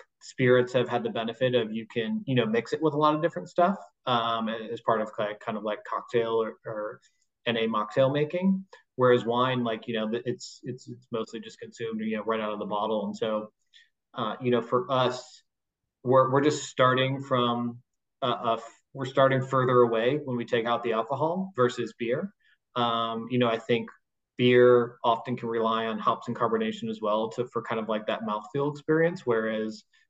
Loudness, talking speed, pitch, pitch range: -27 LUFS, 200 wpm, 120 Hz, 115-130 Hz